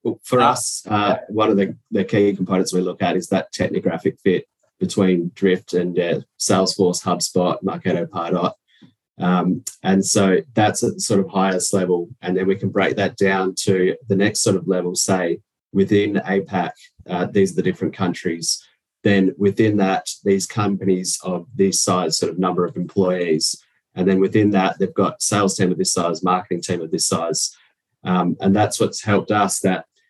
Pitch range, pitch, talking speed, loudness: 90-100 Hz, 95 Hz, 185 wpm, -19 LUFS